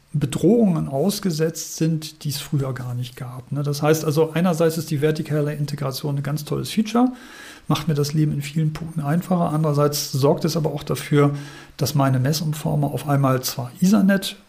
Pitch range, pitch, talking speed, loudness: 145-165 Hz, 155 Hz, 175 wpm, -21 LUFS